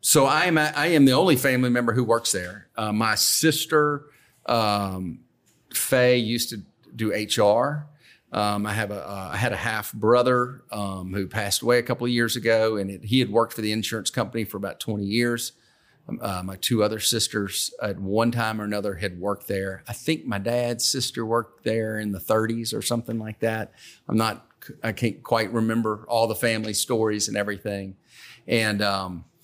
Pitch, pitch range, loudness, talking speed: 110 Hz, 105-120 Hz, -24 LUFS, 195 wpm